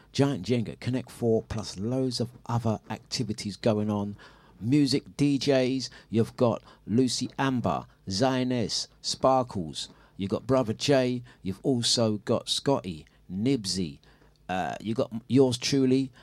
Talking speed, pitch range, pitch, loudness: 120 wpm, 110-130 Hz, 125 Hz, -28 LUFS